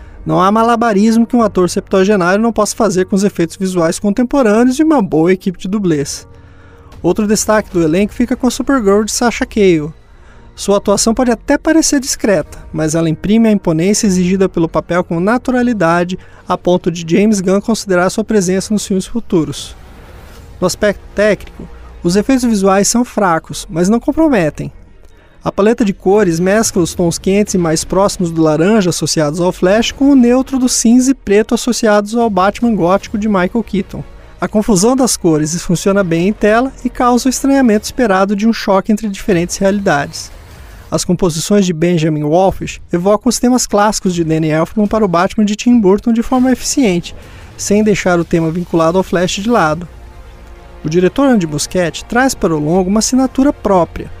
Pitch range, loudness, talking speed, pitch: 170-225 Hz, -13 LUFS, 175 wpm, 195 Hz